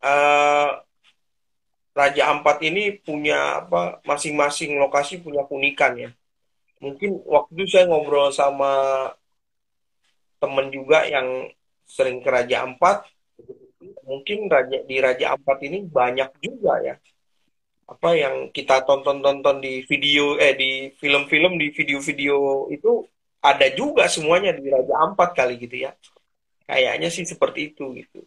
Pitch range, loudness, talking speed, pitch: 135-160 Hz, -20 LUFS, 125 wpm, 145 Hz